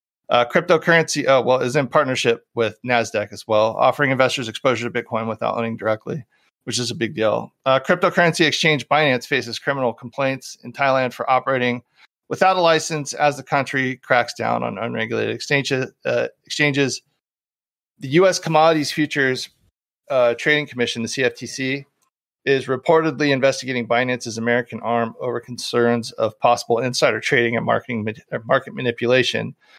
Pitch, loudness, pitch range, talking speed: 130 Hz, -20 LUFS, 120-145 Hz, 145 wpm